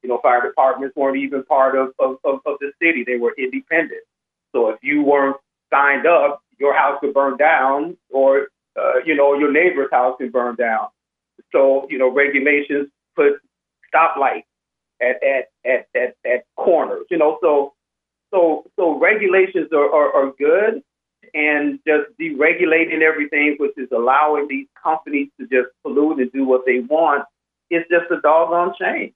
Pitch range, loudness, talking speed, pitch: 135-165 Hz, -17 LUFS, 165 wpm, 145 Hz